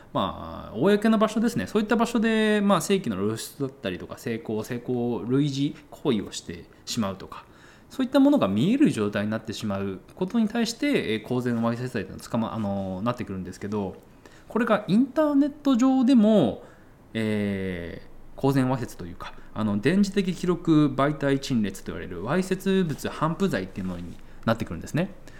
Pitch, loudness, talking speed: 135 Hz, -25 LUFS, 375 characters per minute